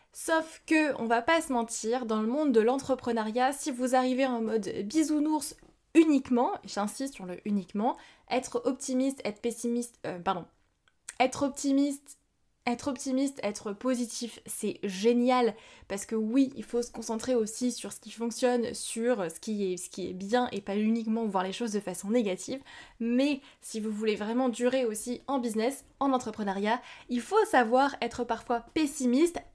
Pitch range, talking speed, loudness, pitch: 220-265 Hz, 165 wpm, -30 LUFS, 240 Hz